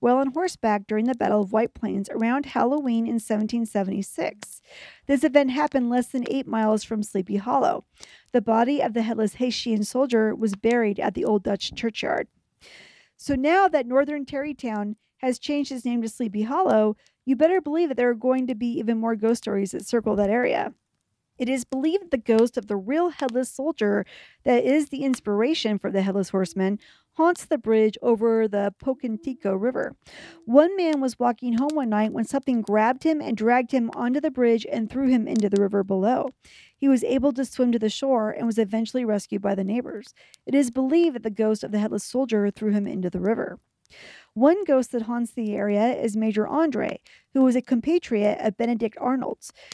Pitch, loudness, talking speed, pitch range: 235 Hz, -24 LUFS, 195 wpm, 215-265 Hz